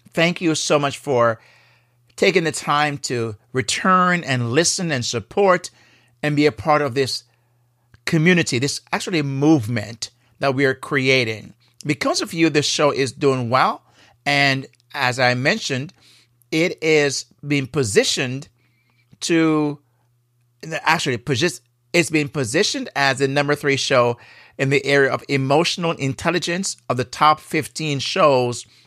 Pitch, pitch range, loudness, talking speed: 140 Hz, 120-155 Hz, -19 LUFS, 135 wpm